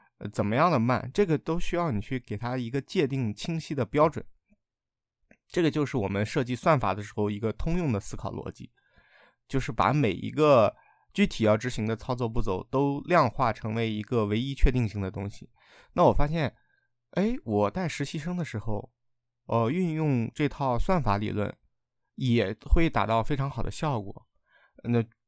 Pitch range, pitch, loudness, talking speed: 110-150 Hz, 125 Hz, -28 LUFS, 265 characters per minute